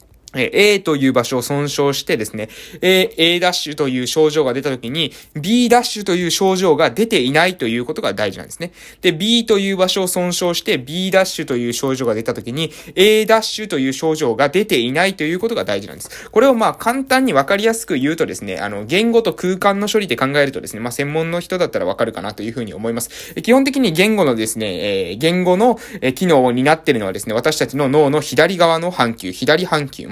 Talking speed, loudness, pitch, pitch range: 410 characters per minute, -16 LUFS, 165 Hz, 135-200 Hz